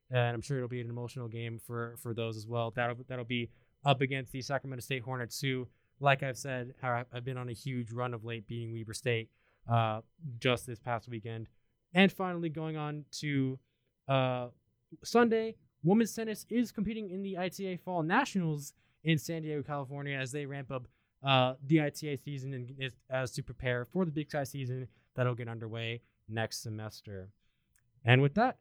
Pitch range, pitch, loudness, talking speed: 120-145 Hz, 130 Hz, -34 LUFS, 185 wpm